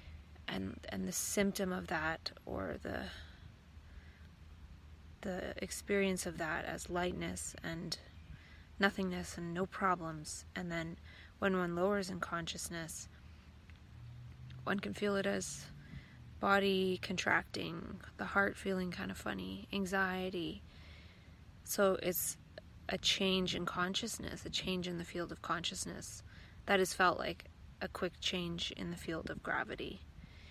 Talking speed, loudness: 130 wpm, -38 LUFS